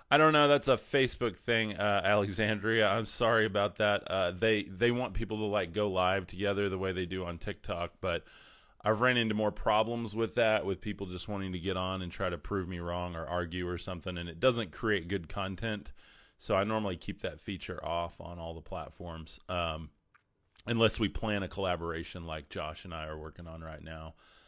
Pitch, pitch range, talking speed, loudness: 95 Hz, 85-110 Hz, 210 wpm, -32 LUFS